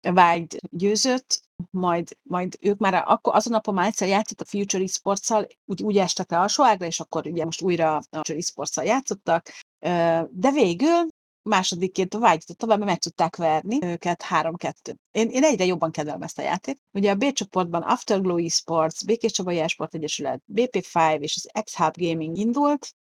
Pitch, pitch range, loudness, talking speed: 185 Hz, 165-215 Hz, -23 LUFS, 165 wpm